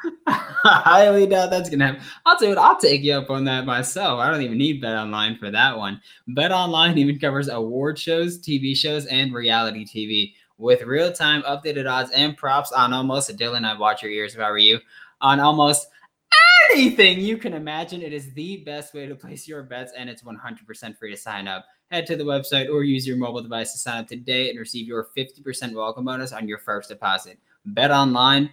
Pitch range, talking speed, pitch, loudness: 120-155 Hz, 215 wpm, 140 Hz, -19 LUFS